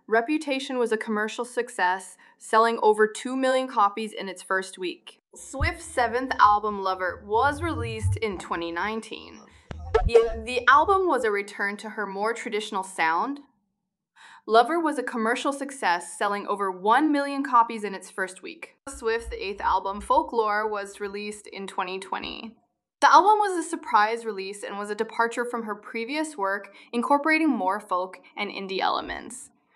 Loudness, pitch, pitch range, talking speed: -25 LUFS, 220 Hz, 200-260 Hz, 150 wpm